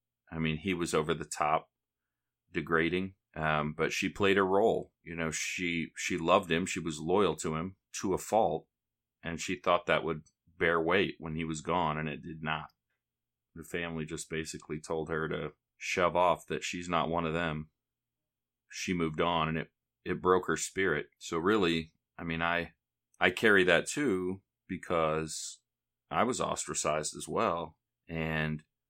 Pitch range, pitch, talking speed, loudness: 75-85 Hz, 80 Hz, 170 wpm, -32 LUFS